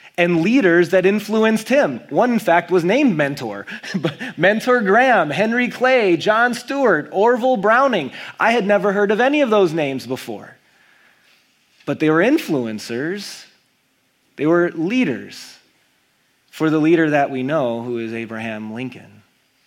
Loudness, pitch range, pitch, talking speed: -17 LUFS, 145-235 Hz, 185 Hz, 140 wpm